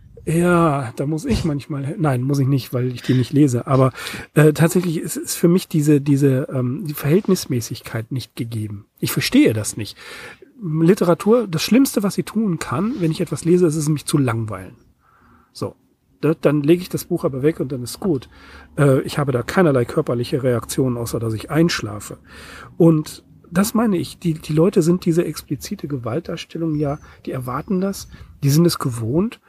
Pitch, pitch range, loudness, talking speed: 155 Hz, 130-170 Hz, -19 LUFS, 185 wpm